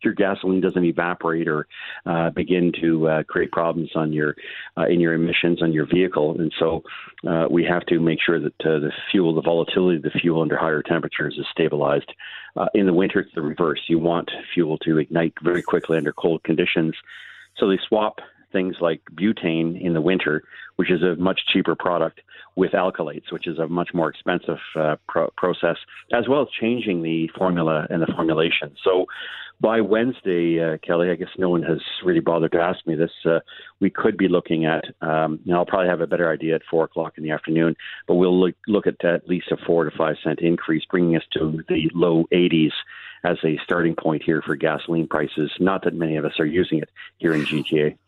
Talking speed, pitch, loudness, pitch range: 210 wpm, 85 Hz, -22 LUFS, 80-90 Hz